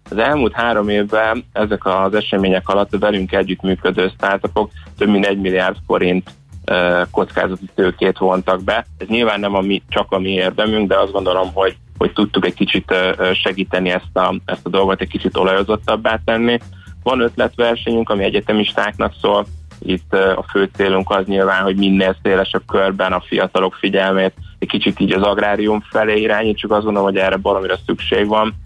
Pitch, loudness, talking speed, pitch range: 95 Hz, -16 LUFS, 170 wpm, 95-105 Hz